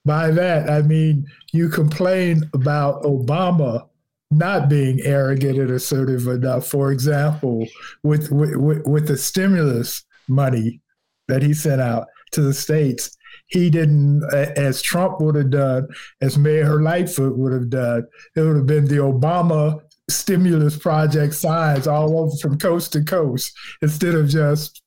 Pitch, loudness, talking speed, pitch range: 150 Hz, -18 LUFS, 145 wpm, 135-155 Hz